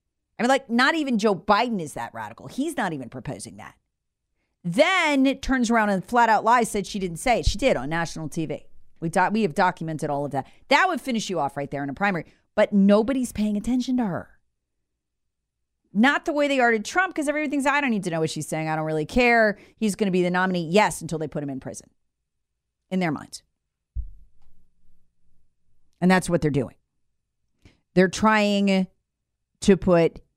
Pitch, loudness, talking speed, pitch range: 185 Hz, -23 LUFS, 205 wpm, 150-235 Hz